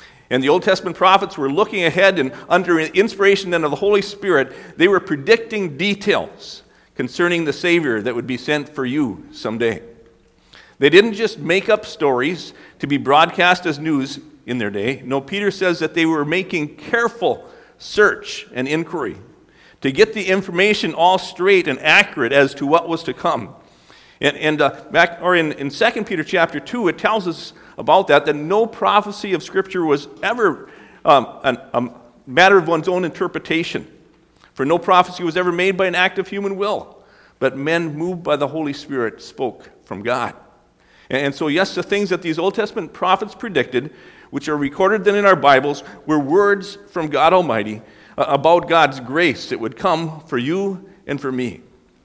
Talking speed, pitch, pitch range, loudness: 180 wpm, 170 Hz, 145-195 Hz, -18 LUFS